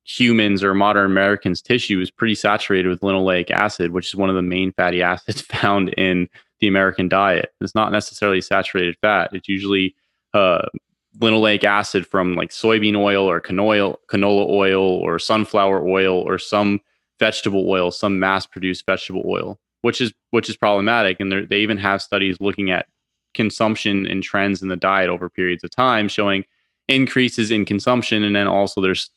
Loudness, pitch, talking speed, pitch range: -18 LUFS, 100 Hz, 170 wpm, 95-105 Hz